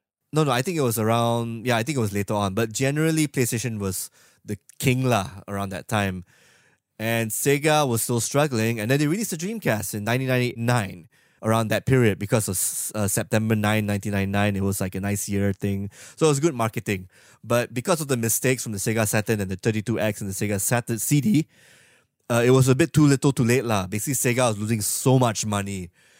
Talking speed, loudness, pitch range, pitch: 210 wpm, -23 LUFS, 105-130 Hz, 115 Hz